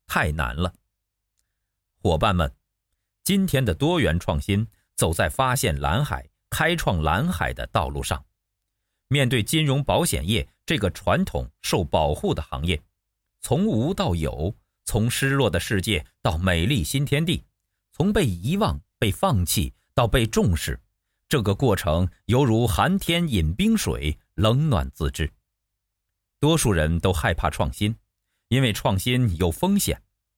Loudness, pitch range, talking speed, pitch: -23 LUFS, 90-125 Hz, 200 characters per minute, 100 Hz